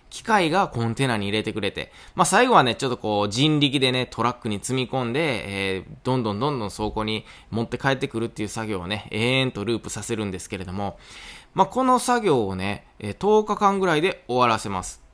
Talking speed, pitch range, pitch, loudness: 415 characters per minute, 105-135 Hz, 115 Hz, -23 LUFS